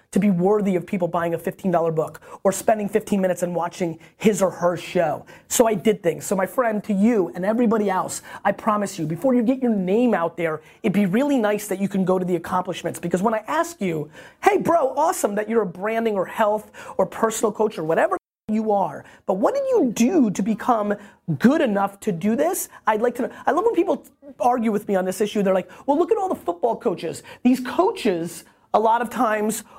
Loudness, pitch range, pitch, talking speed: -22 LUFS, 185-245 Hz, 210 Hz, 230 wpm